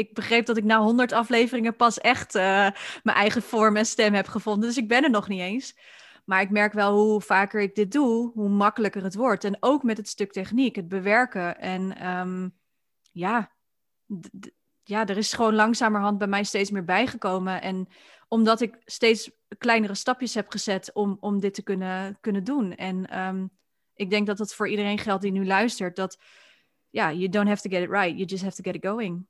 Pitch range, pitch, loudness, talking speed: 195-225 Hz, 210 Hz, -24 LUFS, 215 wpm